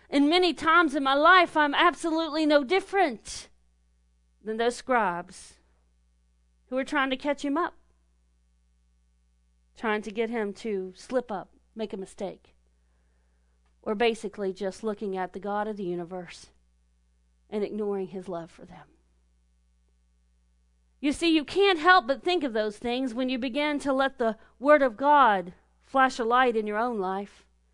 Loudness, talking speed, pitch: -26 LUFS, 155 wpm, 205 Hz